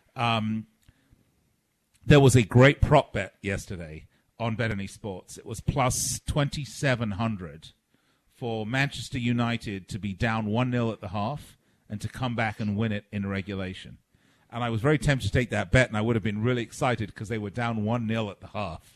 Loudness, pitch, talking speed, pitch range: -26 LUFS, 115 Hz, 190 wpm, 105-125 Hz